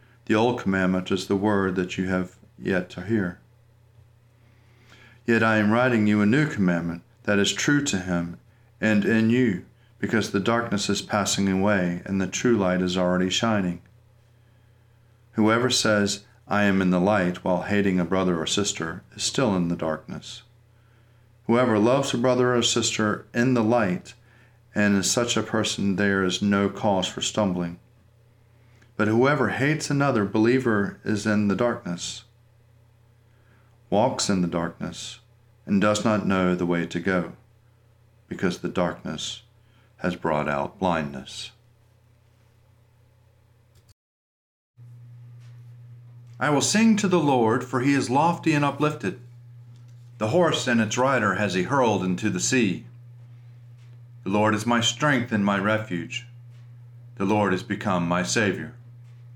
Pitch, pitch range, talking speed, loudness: 115 Hz, 100-120 Hz, 145 wpm, -23 LUFS